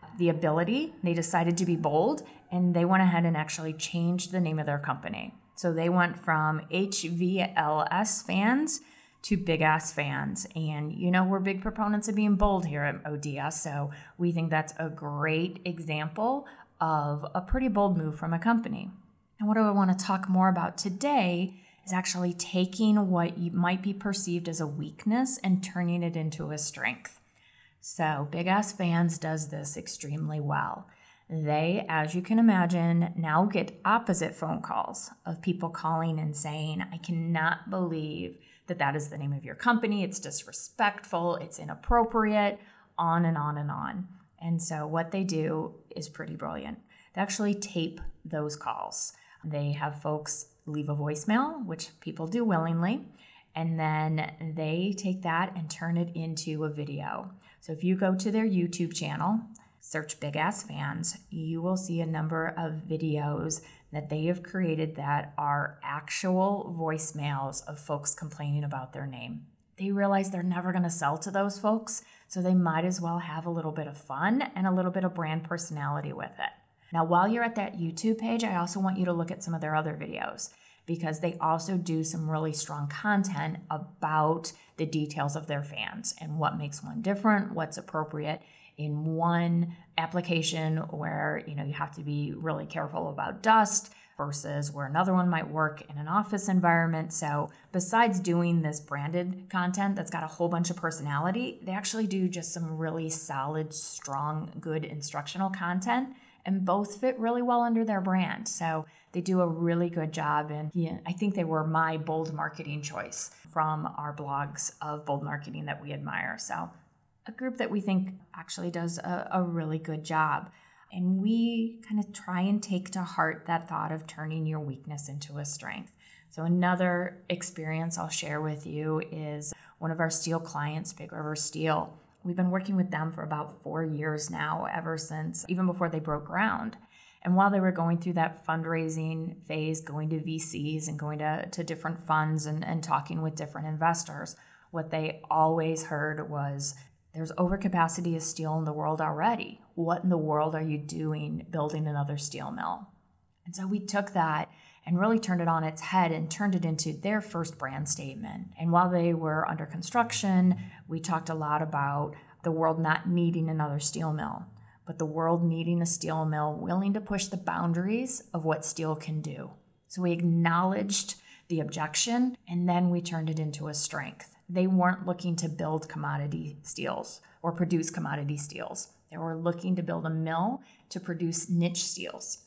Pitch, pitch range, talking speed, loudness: 165 Hz, 155-185 Hz, 180 wpm, -30 LUFS